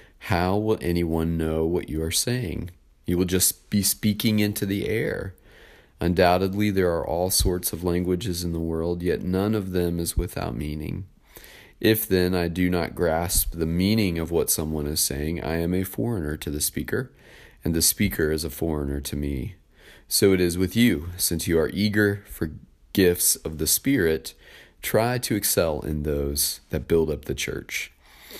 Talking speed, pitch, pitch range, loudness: 180 wpm, 90 Hz, 80-100 Hz, -24 LUFS